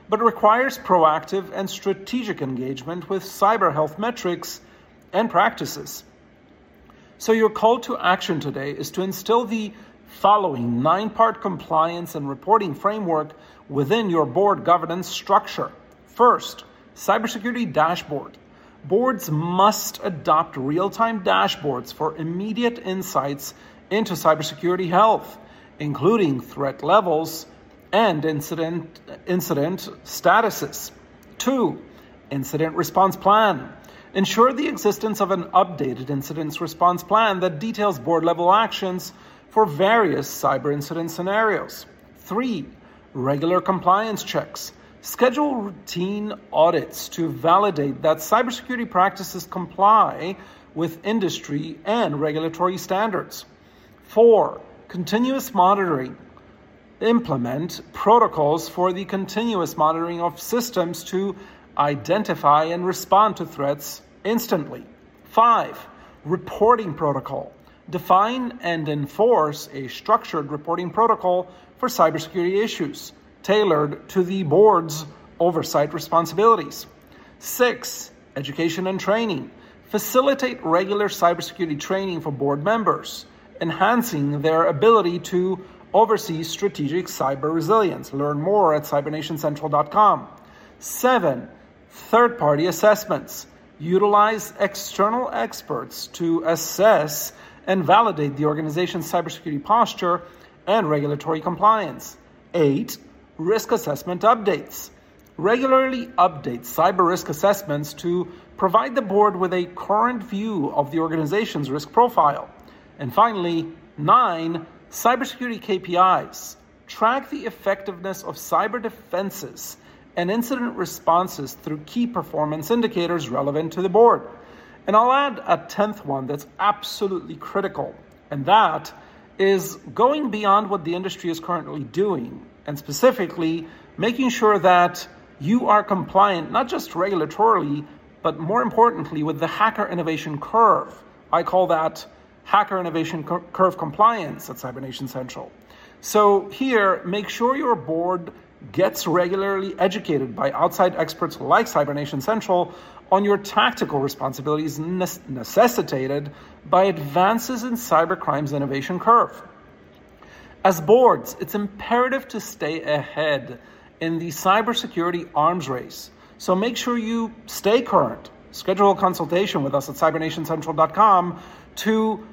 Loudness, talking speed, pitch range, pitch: -21 LUFS, 110 wpm, 160-215 Hz, 180 Hz